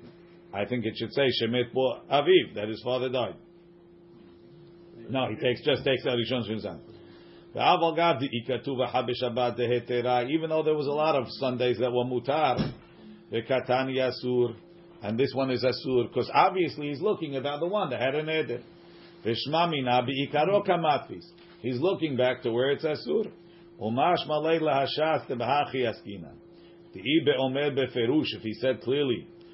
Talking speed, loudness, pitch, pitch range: 160 wpm, -27 LUFS, 135 Hz, 125-170 Hz